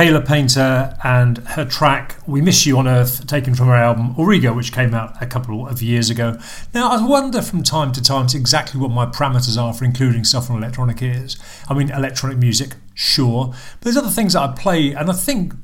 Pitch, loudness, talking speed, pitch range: 130 Hz, -16 LUFS, 215 wpm, 120-150 Hz